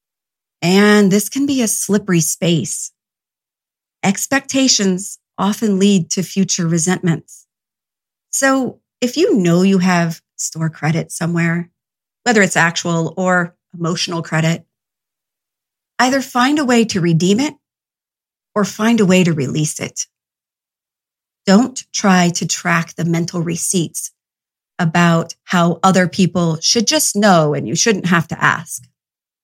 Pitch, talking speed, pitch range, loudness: 180 Hz, 125 wpm, 170-205 Hz, -15 LUFS